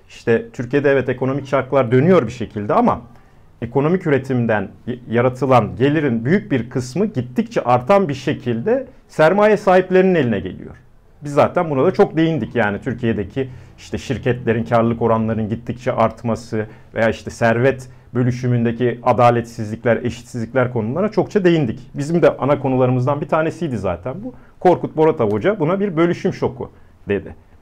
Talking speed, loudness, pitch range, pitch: 140 wpm, -18 LUFS, 115-155 Hz, 125 Hz